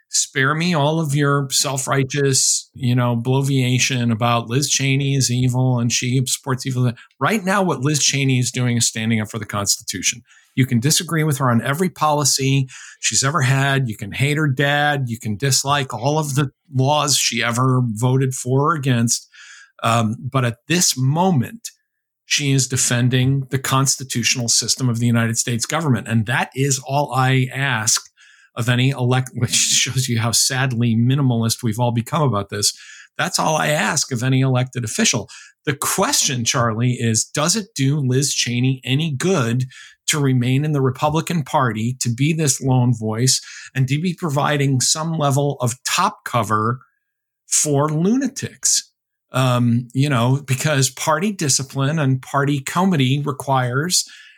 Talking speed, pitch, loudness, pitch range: 165 wpm, 135 Hz, -18 LUFS, 125-145 Hz